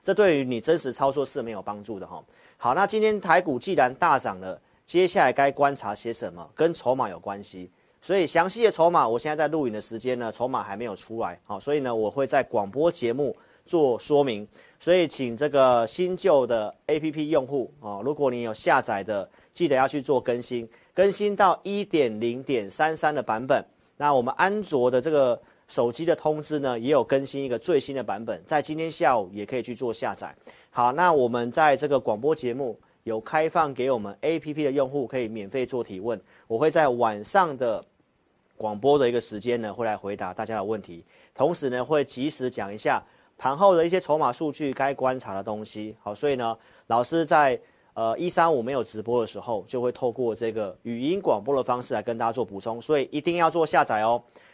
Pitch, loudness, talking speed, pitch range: 130 Hz, -25 LUFS, 310 characters per minute, 115-155 Hz